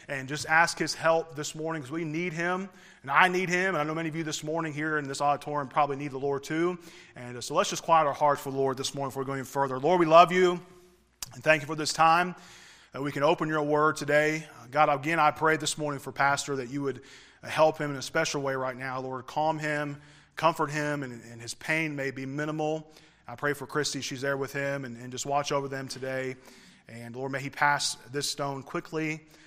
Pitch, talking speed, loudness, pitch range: 150 Hz, 245 wpm, -28 LUFS, 135-160 Hz